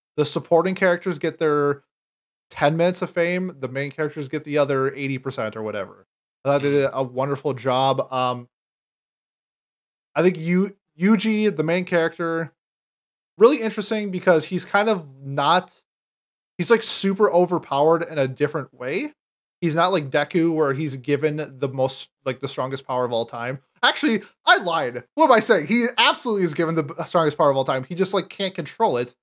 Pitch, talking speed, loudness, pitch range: 160 Hz, 180 wpm, -22 LUFS, 140-180 Hz